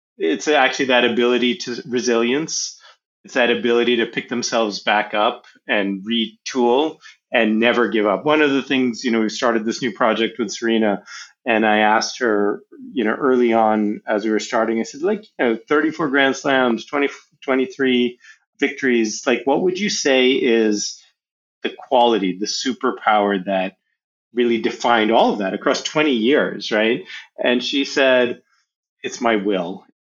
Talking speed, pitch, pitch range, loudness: 165 wpm, 120 Hz, 110-130 Hz, -19 LUFS